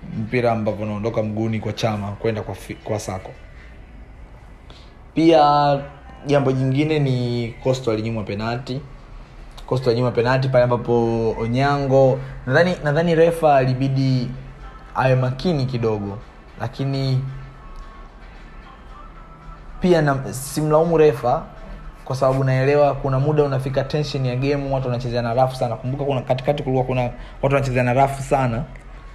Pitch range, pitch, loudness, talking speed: 120-140 Hz, 130 Hz, -20 LUFS, 105 wpm